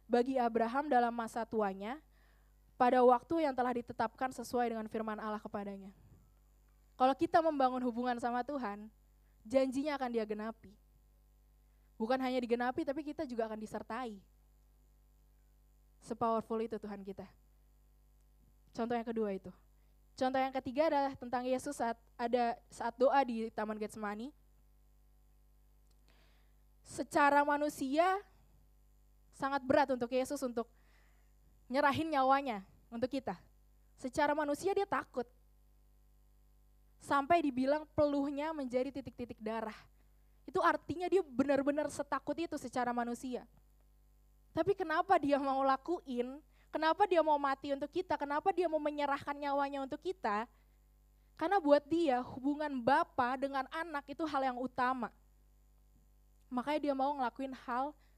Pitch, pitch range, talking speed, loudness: 260 Hz, 230-290 Hz, 120 wpm, -35 LUFS